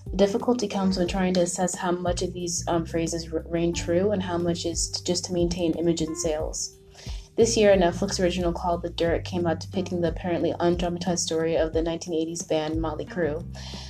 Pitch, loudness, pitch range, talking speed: 170 Hz, -26 LUFS, 165-180 Hz, 205 wpm